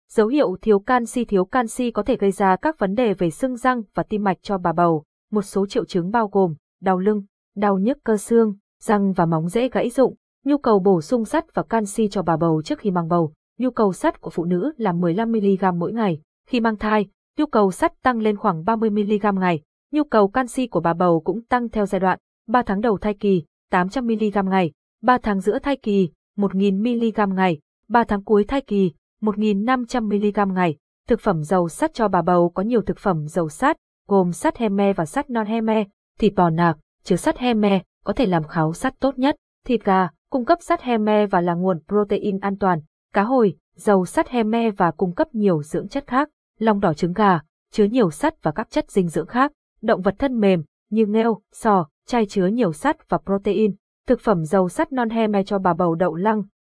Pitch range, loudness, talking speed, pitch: 185-235 Hz, -21 LUFS, 220 wpm, 205 Hz